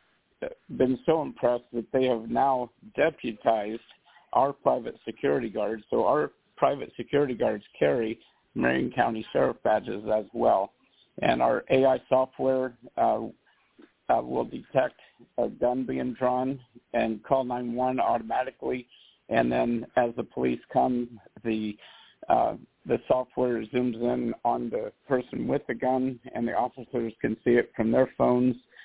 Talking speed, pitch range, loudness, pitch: 140 wpm, 115-130 Hz, -27 LUFS, 120 Hz